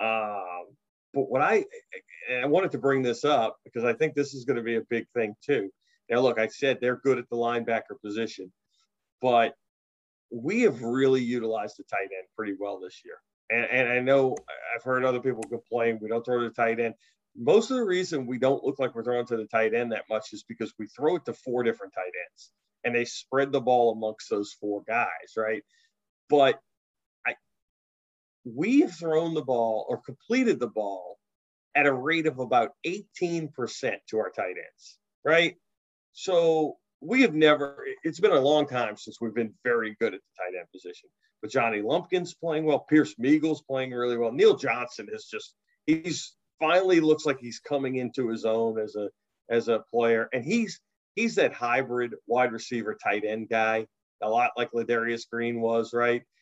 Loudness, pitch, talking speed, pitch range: -27 LUFS, 125 Hz, 190 wpm, 115-155 Hz